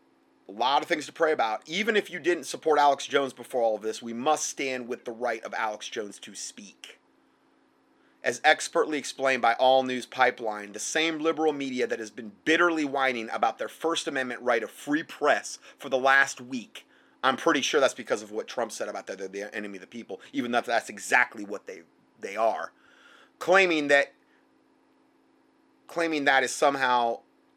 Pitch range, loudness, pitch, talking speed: 125-170 Hz, -26 LUFS, 140 Hz, 190 wpm